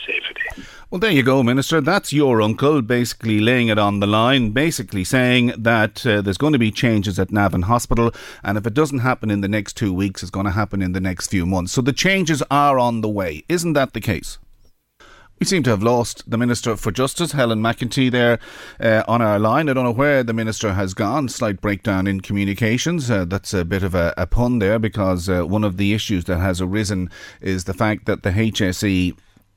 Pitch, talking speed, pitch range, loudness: 110 Hz, 220 wpm, 100-130 Hz, -19 LUFS